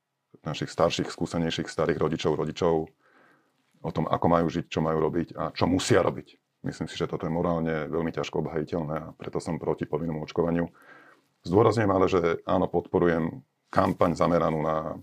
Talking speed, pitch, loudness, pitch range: 165 wpm, 80 Hz, -27 LUFS, 80-85 Hz